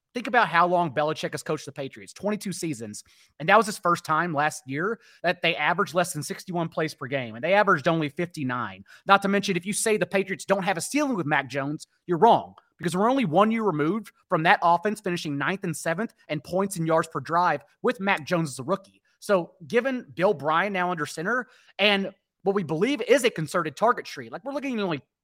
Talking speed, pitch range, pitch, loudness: 230 wpm, 155-205 Hz, 175 Hz, -25 LUFS